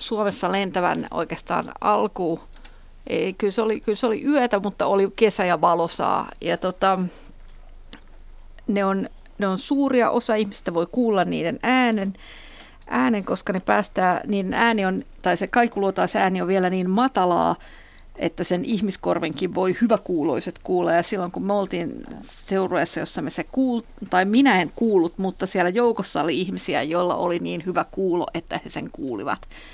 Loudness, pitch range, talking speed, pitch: -23 LUFS, 185-225 Hz, 160 wpm, 195 Hz